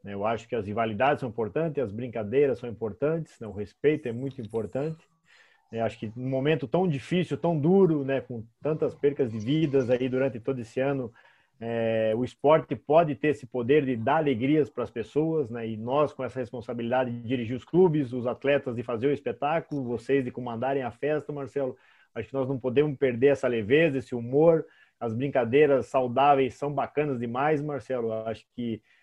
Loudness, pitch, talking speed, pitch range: -27 LUFS, 130 Hz, 190 wpm, 120-145 Hz